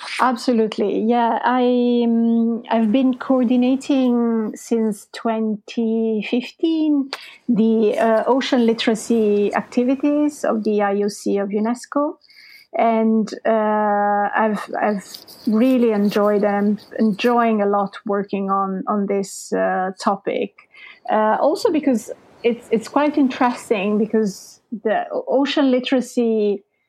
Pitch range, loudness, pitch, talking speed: 210-255 Hz, -19 LUFS, 230 Hz, 105 wpm